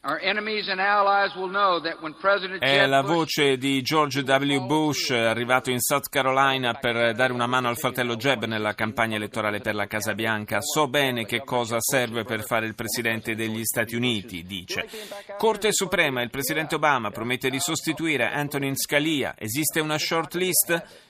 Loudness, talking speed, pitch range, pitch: -24 LUFS, 145 wpm, 115-160 Hz, 135 Hz